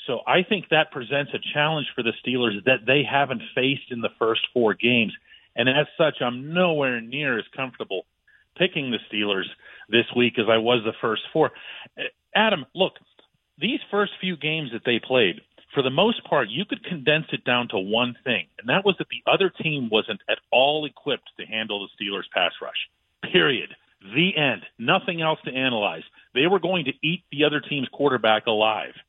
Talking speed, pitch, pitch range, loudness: 190 wpm, 140 Hz, 120-165 Hz, -23 LUFS